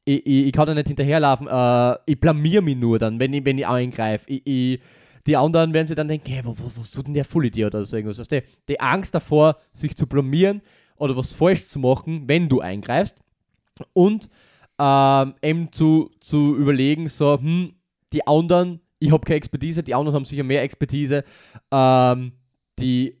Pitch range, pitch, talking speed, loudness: 130-155 Hz, 145 Hz, 195 wpm, -20 LUFS